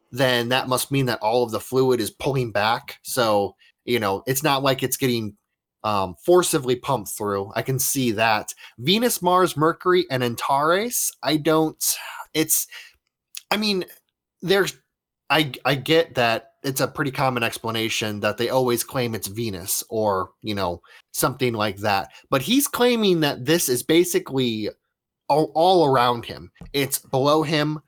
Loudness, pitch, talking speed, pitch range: -22 LUFS, 130 Hz, 160 wpm, 115-160 Hz